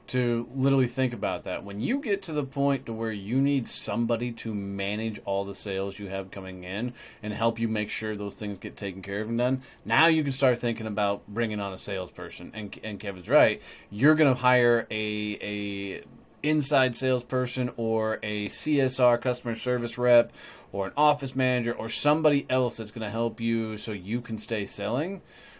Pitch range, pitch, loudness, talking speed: 105-130 Hz, 115 Hz, -27 LUFS, 195 wpm